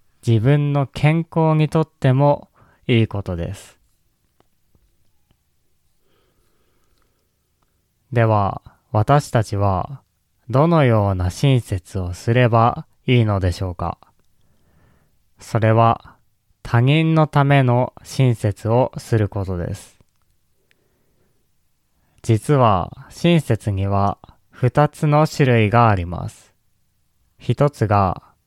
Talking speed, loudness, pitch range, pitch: 160 characters per minute, -18 LUFS, 100-140 Hz, 115 Hz